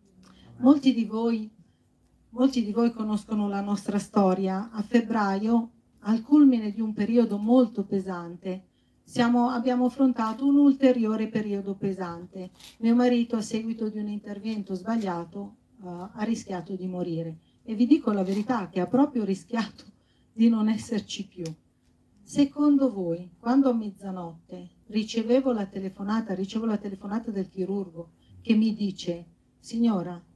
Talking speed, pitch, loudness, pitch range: 135 wpm, 215 Hz, -26 LUFS, 190-235 Hz